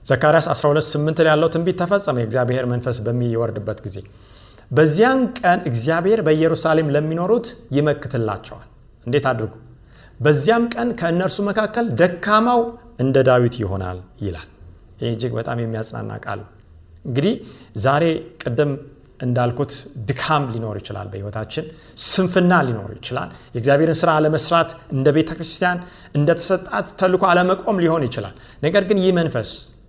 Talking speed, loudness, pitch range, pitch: 115 wpm, -19 LUFS, 115-170 Hz, 145 Hz